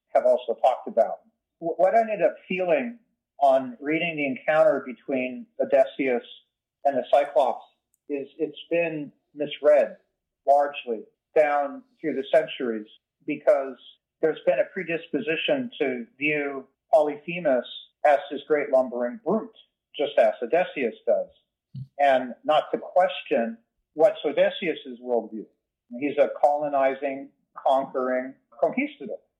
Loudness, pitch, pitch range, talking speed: -25 LUFS, 145 Hz, 135-180 Hz, 115 wpm